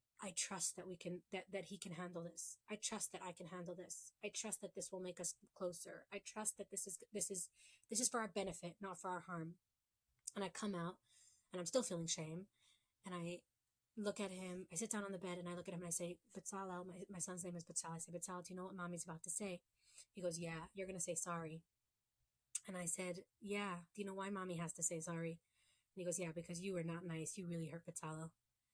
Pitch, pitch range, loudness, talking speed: 180 Hz, 170-195 Hz, -47 LUFS, 255 wpm